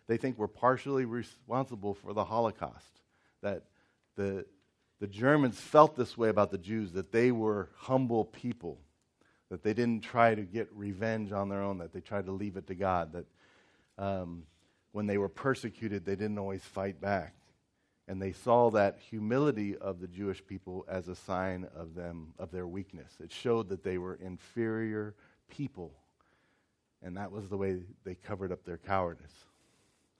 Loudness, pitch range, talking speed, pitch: -33 LUFS, 95-115 Hz, 170 wpm, 100 Hz